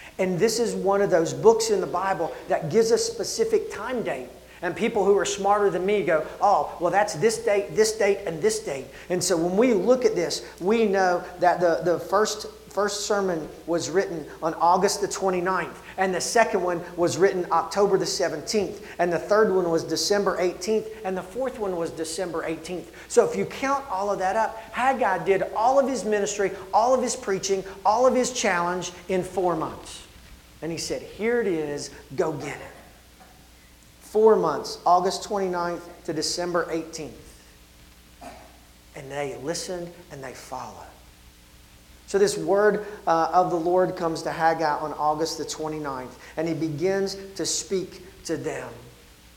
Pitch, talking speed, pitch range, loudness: 185 Hz, 175 wpm, 160-205 Hz, -24 LUFS